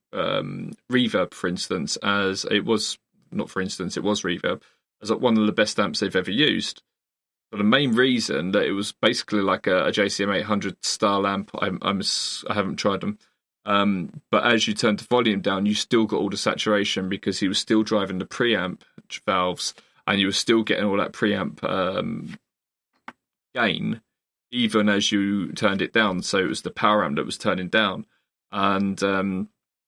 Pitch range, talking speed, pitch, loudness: 100-110 Hz, 185 wpm, 100 Hz, -23 LUFS